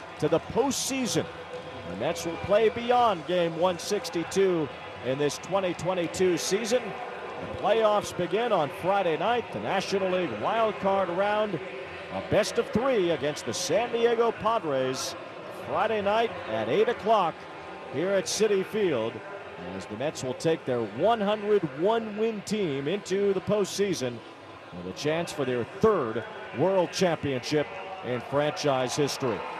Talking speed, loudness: 135 wpm, -27 LUFS